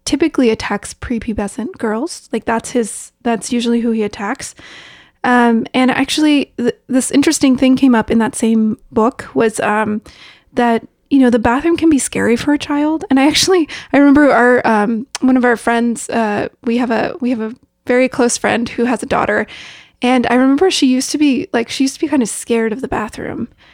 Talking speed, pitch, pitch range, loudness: 205 wpm, 245 Hz, 230-275 Hz, -14 LUFS